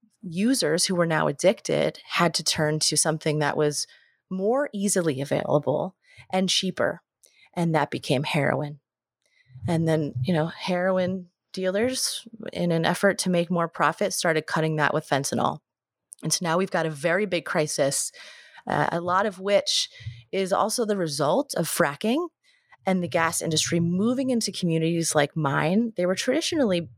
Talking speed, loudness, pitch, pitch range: 160 wpm, -24 LUFS, 175 Hz, 155-200 Hz